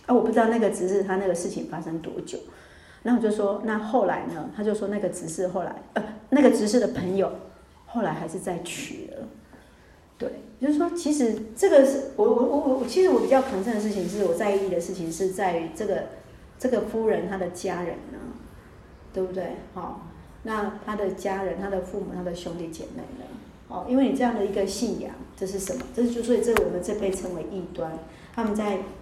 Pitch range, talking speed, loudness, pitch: 185-230 Hz, 305 characters per minute, -26 LUFS, 205 Hz